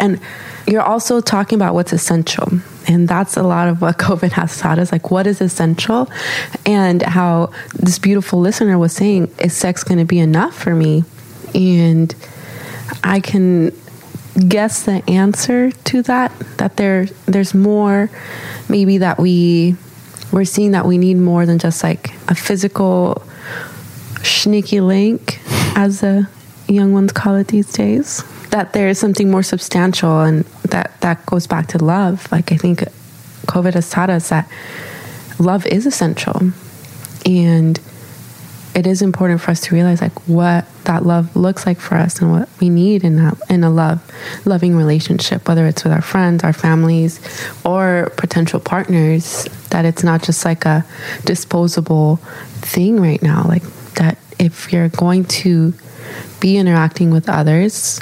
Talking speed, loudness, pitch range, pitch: 160 wpm, -14 LUFS, 165-195 Hz, 175 Hz